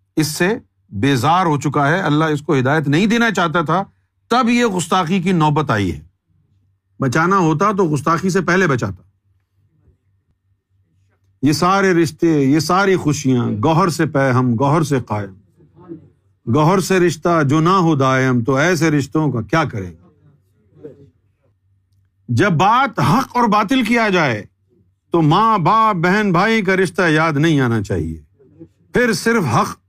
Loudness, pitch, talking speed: -16 LUFS, 150 Hz, 155 wpm